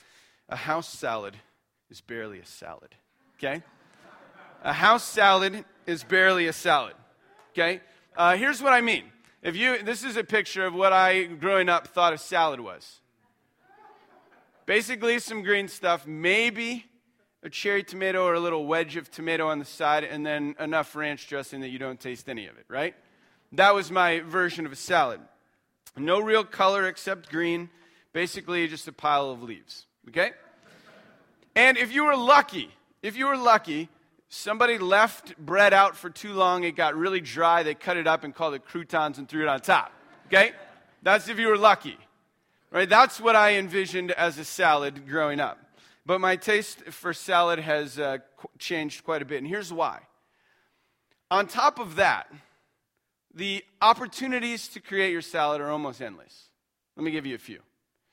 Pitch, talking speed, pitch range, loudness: 180 Hz, 175 wpm, 160-210 Hz, -24 LUFS